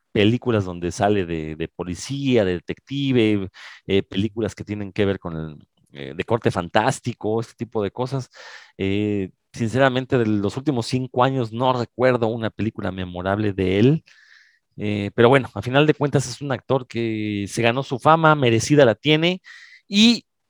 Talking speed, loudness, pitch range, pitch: 165 wpm, -21 LUFS, 100-130 Hz, 115 Hz